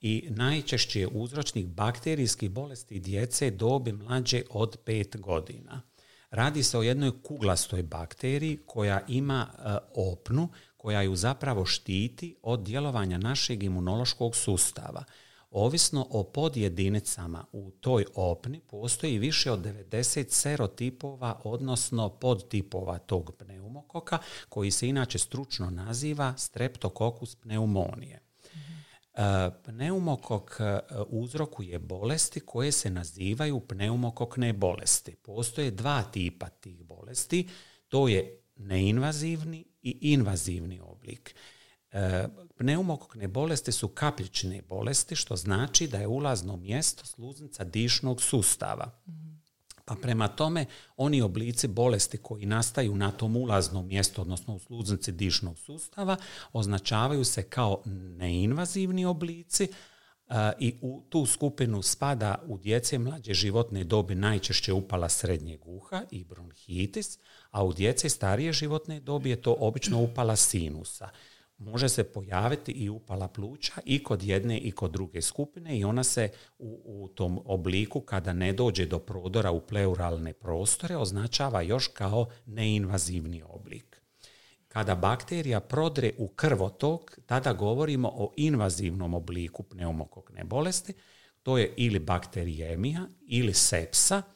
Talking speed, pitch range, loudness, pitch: 120 wpm, 95-135 Hz, -30 LUFS, 115 Hz